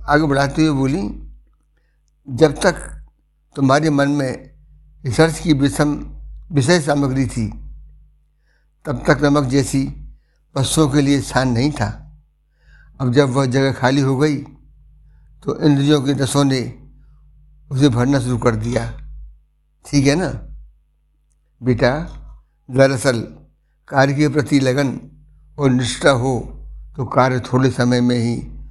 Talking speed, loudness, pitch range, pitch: 125 wpm, -17 LUFS, 120-145 Hz, 135 Hz